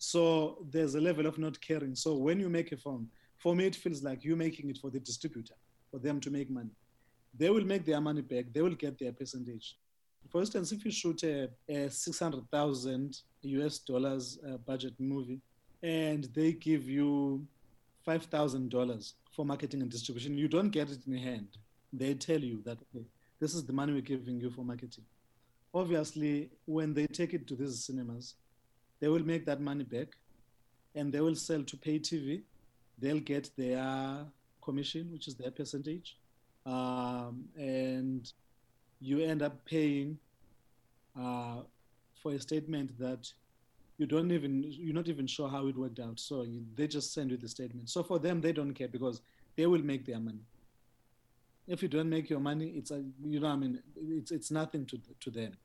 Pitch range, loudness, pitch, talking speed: 125-155 Hz, -36 LUFS, 140 Hz, 185 wpm